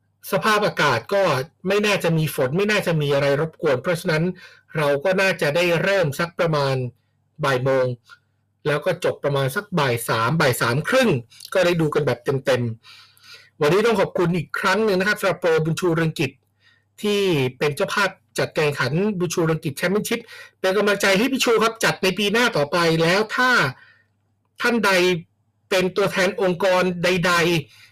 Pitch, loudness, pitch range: 175 Hz, -20 LUFS, 145-195 Hz